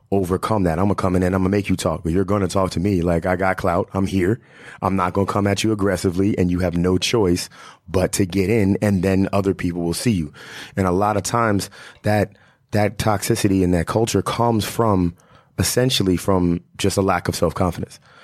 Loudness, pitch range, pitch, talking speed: -20 LUFS, 90-105 Hz, 95 Hz, 225 wpm